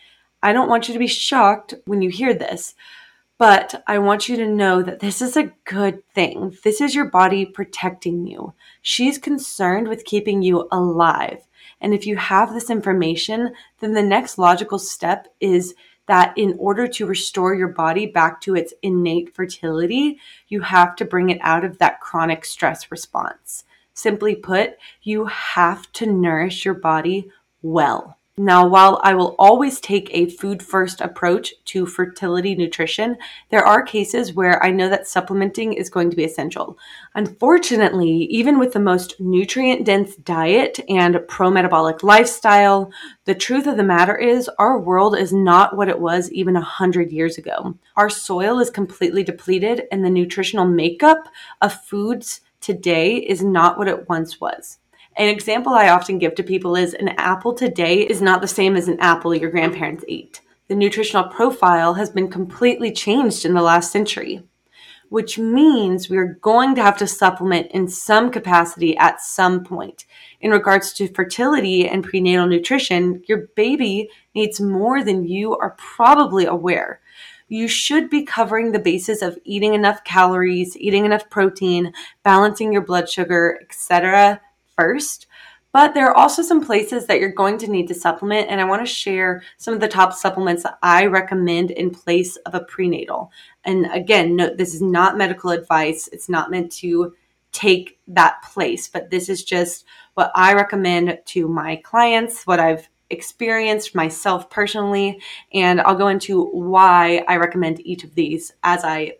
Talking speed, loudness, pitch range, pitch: 170 wpm, -17 LUFS, 180-215 Hz, 190 Hz